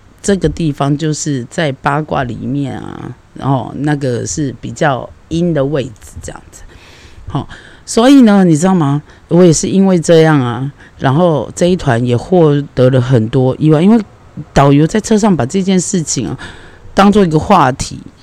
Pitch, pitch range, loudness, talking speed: 150 Hz, 125-175 Hz, -12 LUFS, 245 characters per minute